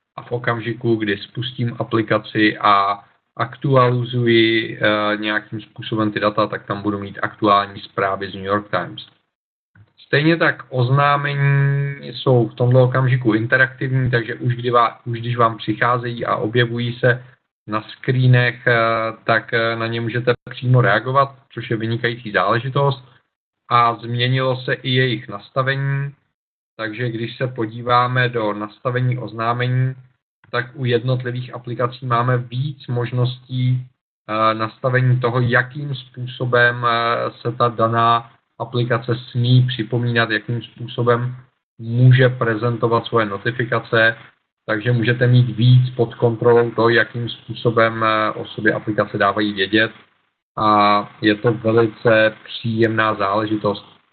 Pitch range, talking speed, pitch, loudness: 110-125 Hz, 120 wpm, 120 Hz, -18 LUFS